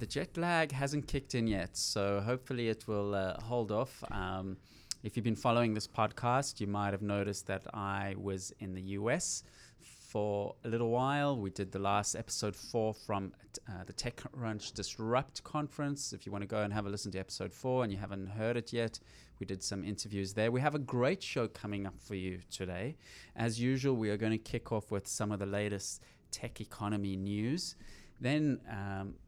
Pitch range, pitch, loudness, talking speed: 100-120 Hz, 105 Hz, -36 LUFS, 200 wpm